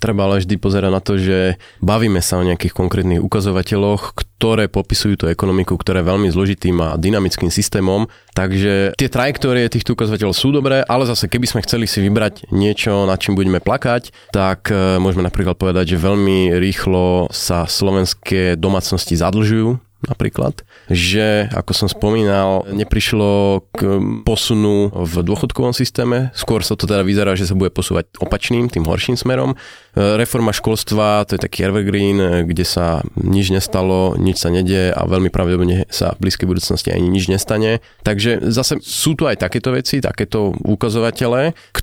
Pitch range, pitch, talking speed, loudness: 95-110 Hz, 100 Hz, 160 wpm, -16 LUFS